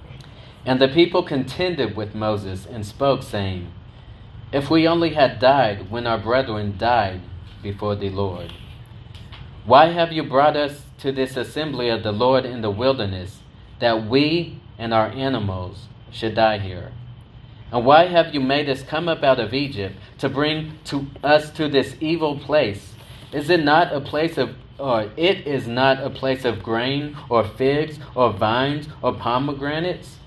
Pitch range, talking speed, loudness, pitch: 110-145 Hz, 165 wpm, -20 LUFS, 125 Hz